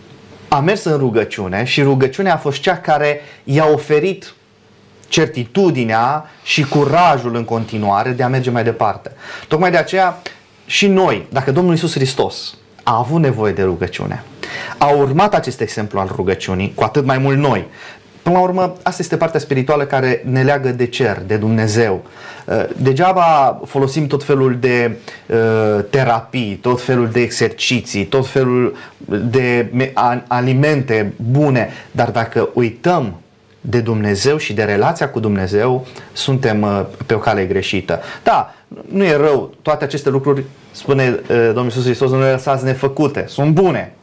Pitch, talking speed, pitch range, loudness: 130 Hz, 145 wpm, 115-150 Hz, -15 LUFS